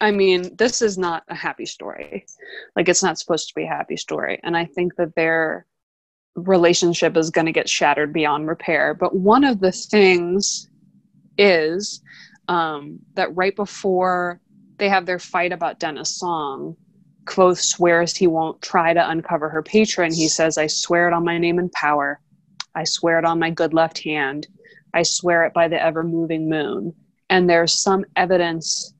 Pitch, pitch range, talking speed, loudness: 170 Hz, 165-185 Hz, 180 wpm, -19 LUFS